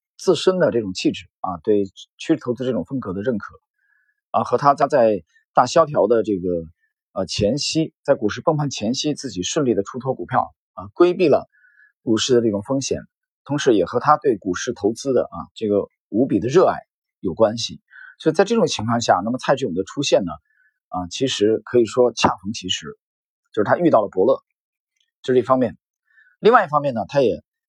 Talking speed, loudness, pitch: 285 characters per minute, -20 LUFS, 135 Hz